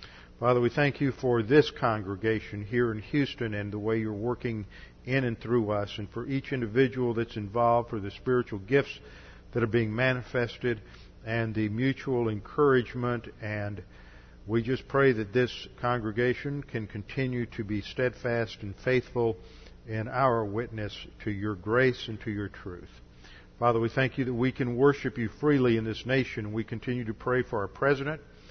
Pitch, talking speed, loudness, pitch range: 120 Hz, 170 wpm, -29 LUFS, 105-130 Hz